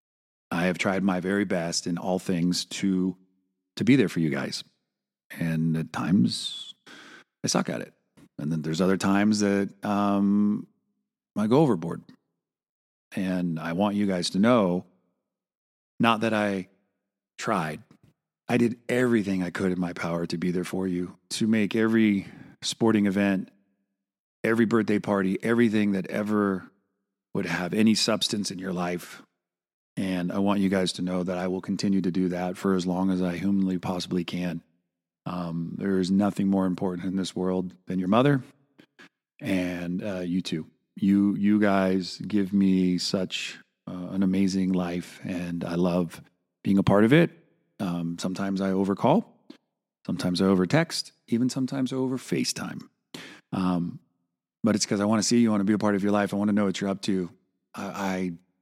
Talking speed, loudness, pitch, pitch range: 175 wpm, -26 LUFS, 95 Hz, 90-100 Hz